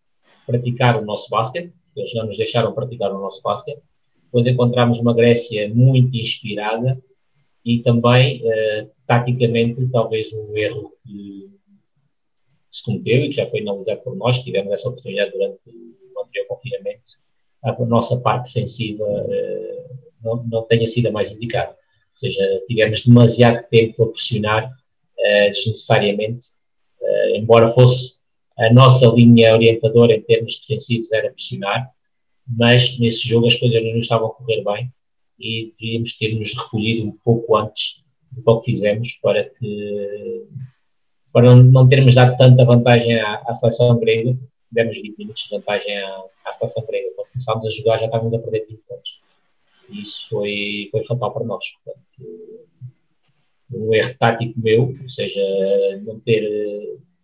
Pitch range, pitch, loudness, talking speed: 110-130 Hz, 115 Hz, -17 LUFS, 150 wpm